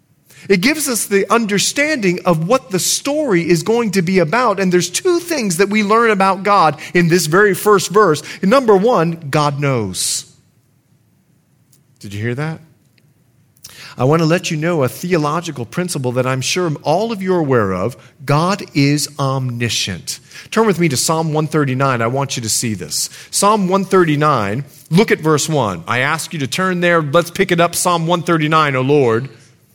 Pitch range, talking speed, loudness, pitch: 135-190 Hz, 180 wpm, -15 LUFS, 160 Hz